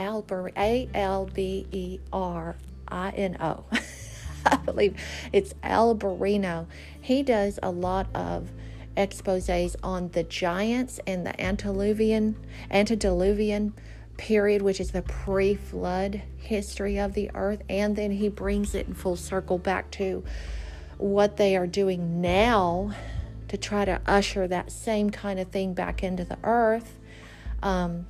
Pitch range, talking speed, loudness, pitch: 180-205 Hz, 125 wpm, -27 LUFS, 195 Hz